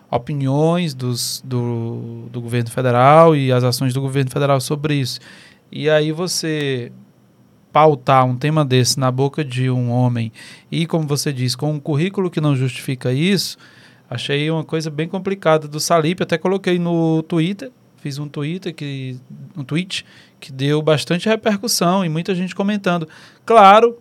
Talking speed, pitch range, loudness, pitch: 155 wpm, 130-170 Hz, -17 LUFS, 150 Hz